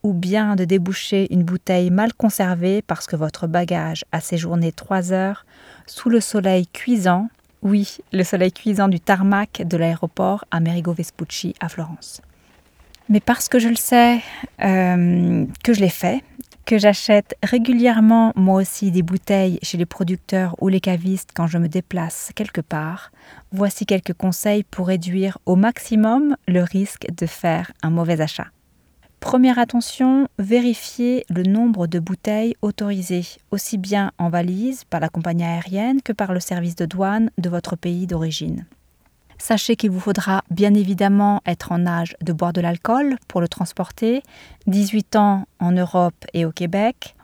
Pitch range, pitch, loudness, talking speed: 175-210 Hz, 190 Hz, -19 LUFS, 160 wpm